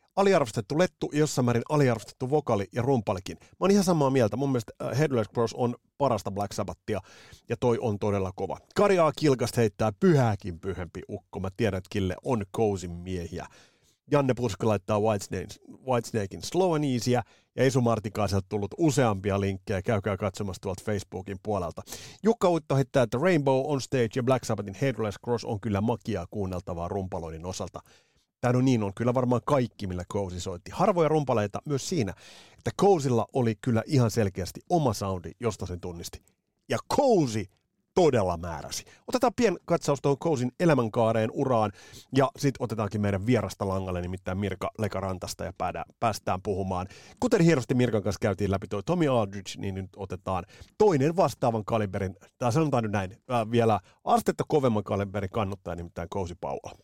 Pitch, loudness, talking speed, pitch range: 110 Hz, -28 LUFS, 155 wpm, 95-130 Hz